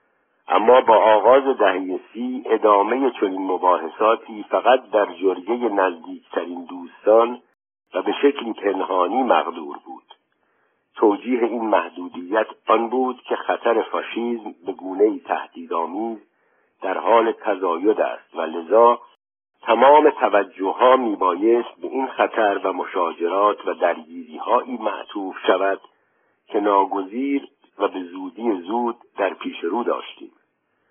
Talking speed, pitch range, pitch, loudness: 115 wpm, 100-135 Hz, 120 Hz, -20 LUFS